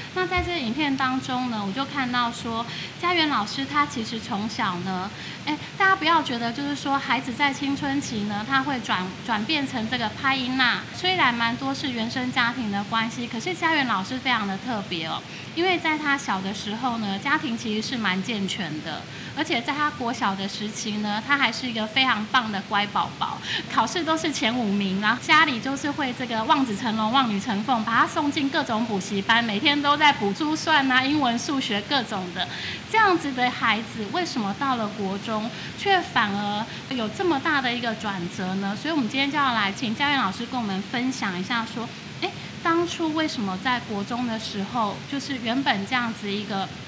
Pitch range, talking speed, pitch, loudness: 210-280 Hz, 300 characters per minute, 240 Hz, -24 LUFS